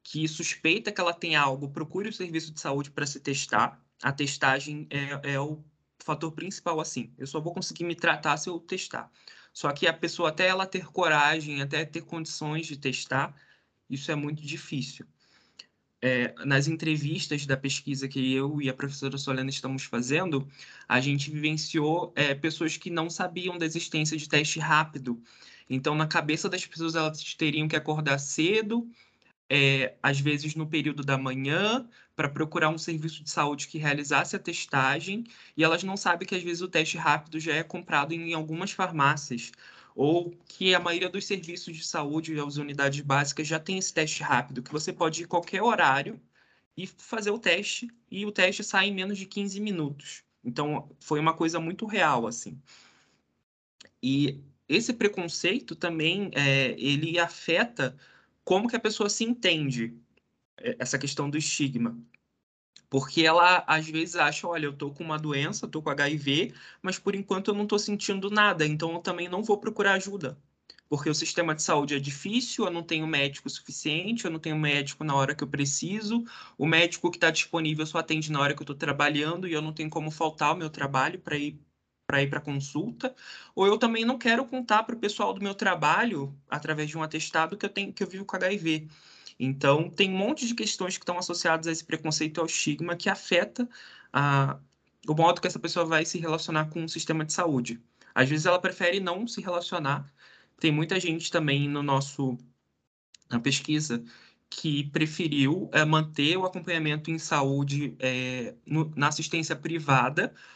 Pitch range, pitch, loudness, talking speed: 145-175 Hz, 155 Hz, -28 LUFS, 185 wpm